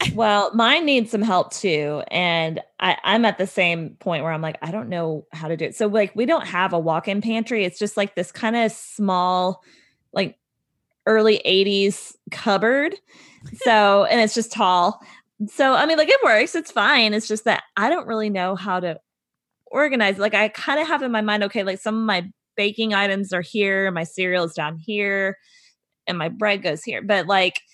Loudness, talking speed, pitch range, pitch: -20 LUFS, 205 wpm, 180-225 Hz, 205 Hz